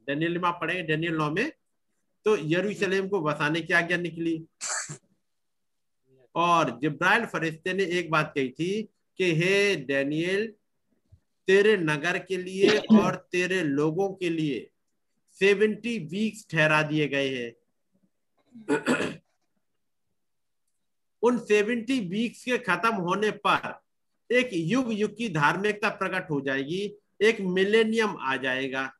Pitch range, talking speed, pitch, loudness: 155-210 Hz, 115 wpm, 180 Hz, -26 LUFS